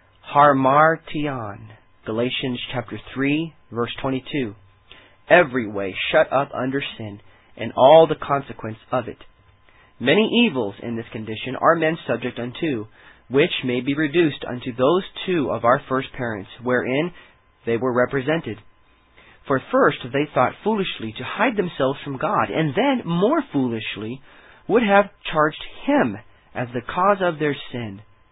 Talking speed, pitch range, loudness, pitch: 140 wpm, 110-155 Hz, -21 LUFS, 130 Hz